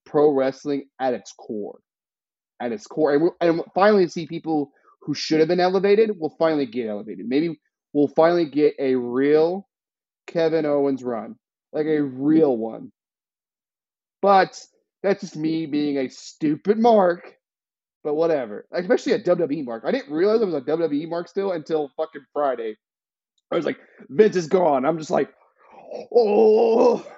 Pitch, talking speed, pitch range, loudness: 160 Hz, 160 wpm, 145-190 Hz, -21 LUFS